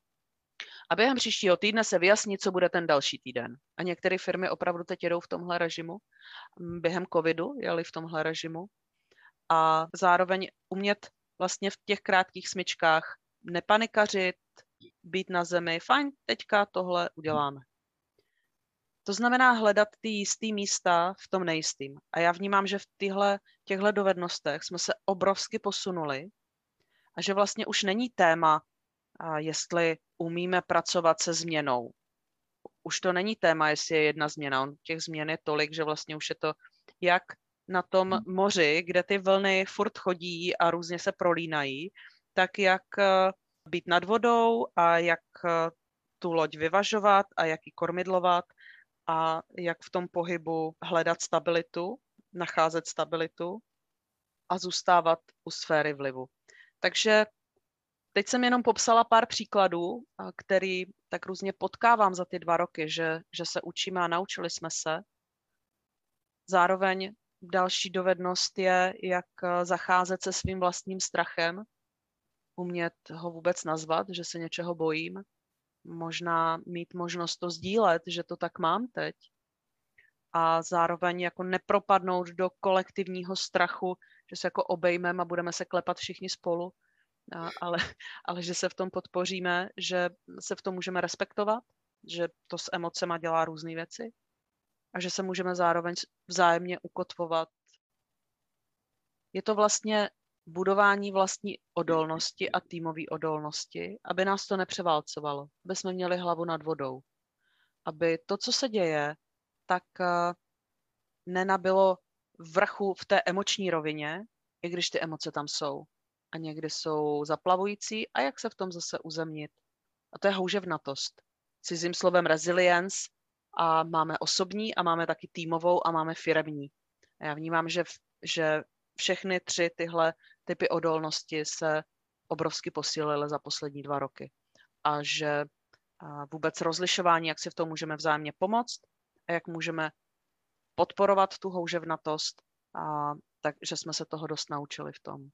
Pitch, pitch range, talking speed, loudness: 175 Hz, 165-190 Hz, 140 wpm, -29 LUFS